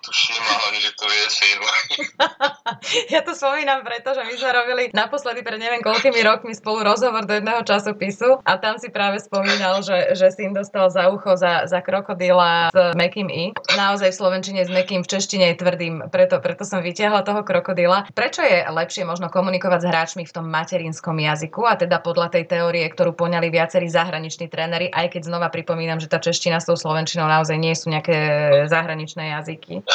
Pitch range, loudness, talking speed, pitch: 170-210 Hz, -19 LUFS, 180 wpm, 185 Hz